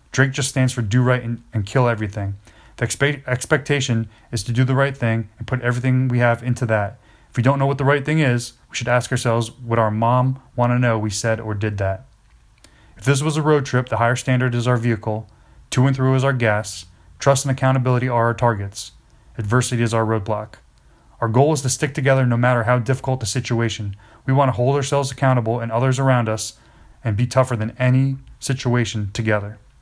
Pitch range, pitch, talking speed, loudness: 115-130 Hz, 120 Hz, 215 wpm, -20 LUFS